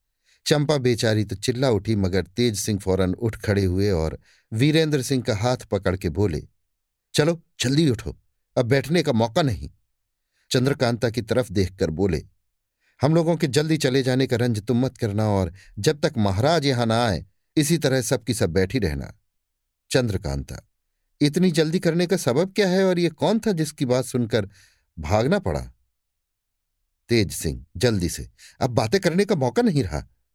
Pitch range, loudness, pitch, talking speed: 95-145 Hz, -23 LUFS, 120 Hz, 170 wpm